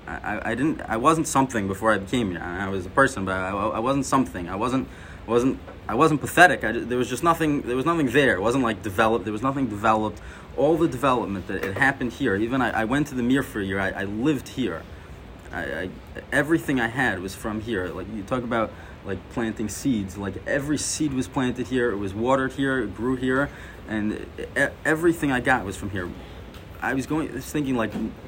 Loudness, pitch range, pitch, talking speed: -24 LUFS, 95-135 Hz, 115 Hz, 240 wpm